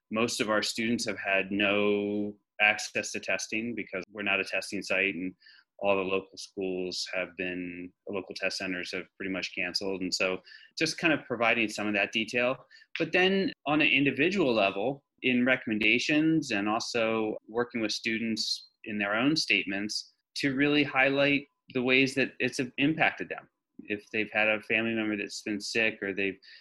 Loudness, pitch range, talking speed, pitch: -28 LUFS, 100-130 Hz, 175 wpm, 110 Hz